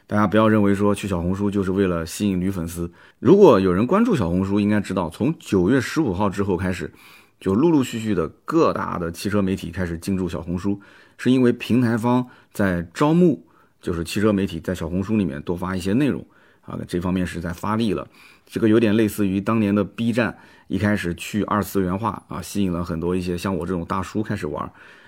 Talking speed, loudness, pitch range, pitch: 325 characters per minute, -21 LUFS, 90-105 Hz, 100 Hz